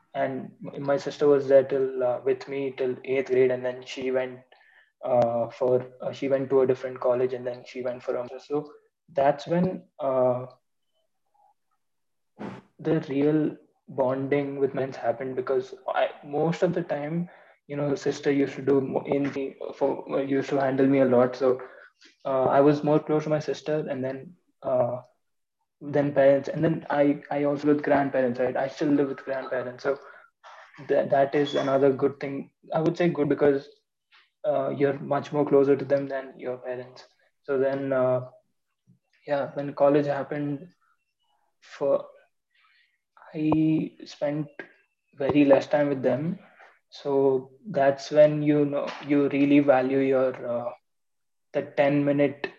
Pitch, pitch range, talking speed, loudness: 140 Hz, 130-150 Hz, 160 wpm, -25 LUFS